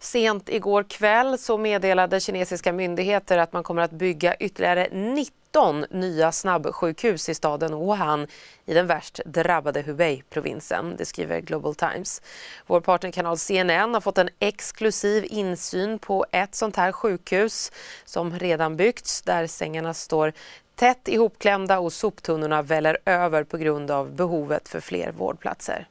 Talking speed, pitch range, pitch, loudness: 140 wpm, 165-205 Hz, 180 Hz, -24 LUFS